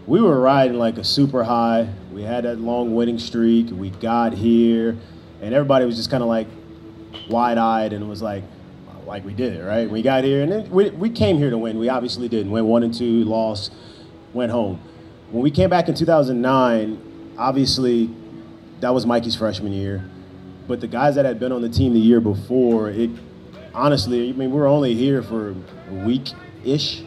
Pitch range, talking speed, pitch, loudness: 110-125 Hz, 195 wpm, 115 Hz, -19 LUFS